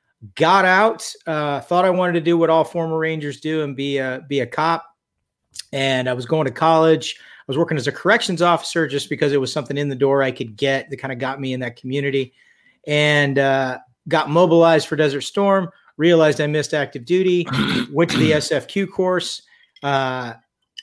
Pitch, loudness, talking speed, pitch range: 150 Hz, -19 LUFS, 200 wpm, 135-170 Hz